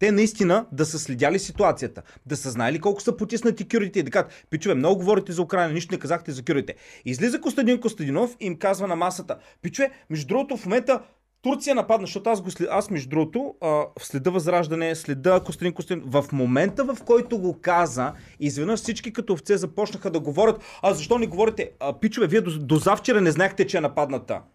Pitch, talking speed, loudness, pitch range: 185 Hz, 195 wpm, -24 LUFS, 160-220 Hz